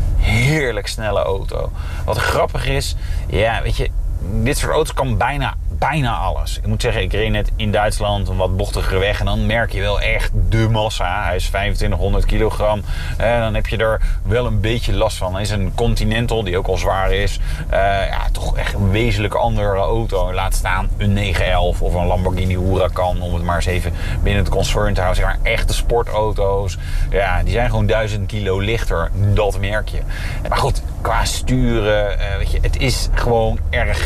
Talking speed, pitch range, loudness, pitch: 195 wpm, 90-110 Hz, -19 LUFS, 100 Hz